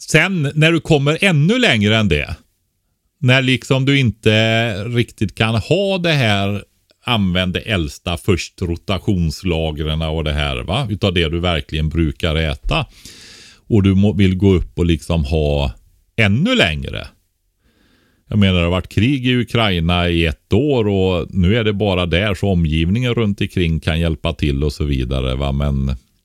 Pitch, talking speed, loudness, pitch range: 95 Hz, 165 wpm, -17 LUFS, 80-110 Hz